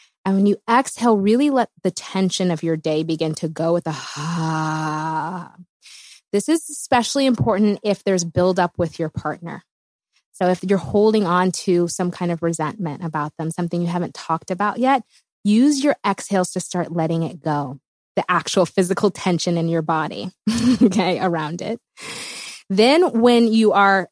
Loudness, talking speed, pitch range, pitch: -20 LUFS, 170 wpm, 165-210 Hz, 180 Hz